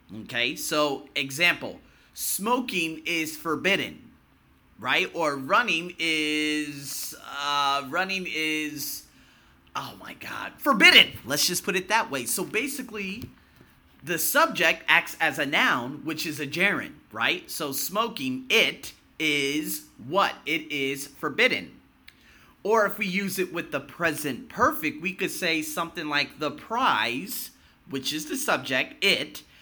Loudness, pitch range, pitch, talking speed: -25 LUFS, 145-190 Hz, 155 Hz, 130 wpm